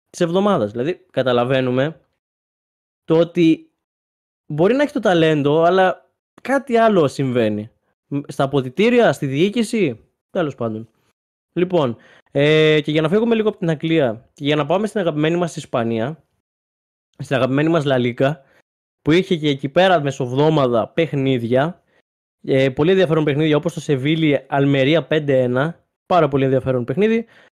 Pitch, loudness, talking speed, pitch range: 155 Hz, -18 LUFS, 135 wpm, 135-175 Hz